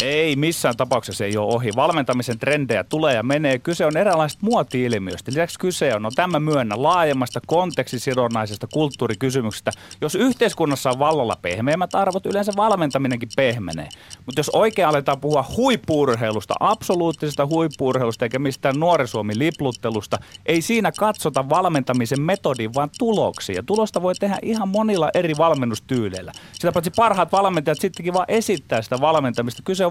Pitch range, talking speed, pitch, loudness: 125-180 Hz, 140 wpm, 145 Hz, -20 LUFS